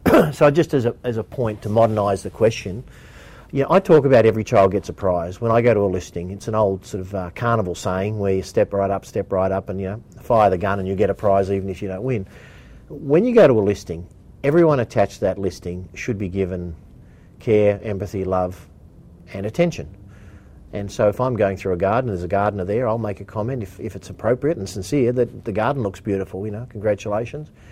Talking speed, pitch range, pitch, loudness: 235 wpm, 95-115 Hz, 100 Hz, -20 LUFS